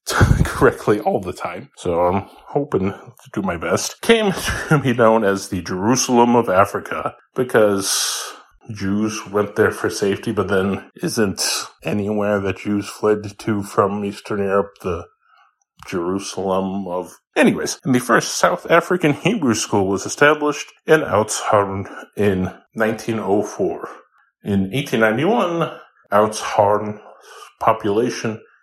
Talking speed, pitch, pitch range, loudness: 120 wpm, 105 Hz, 100-120 Hz, -19 LUFS